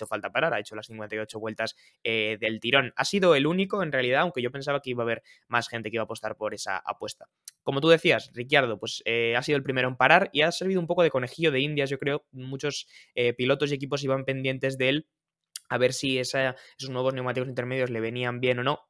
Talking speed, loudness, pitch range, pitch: 245 wpm, -26 LUFS, 115-140 Hz, 130 Hz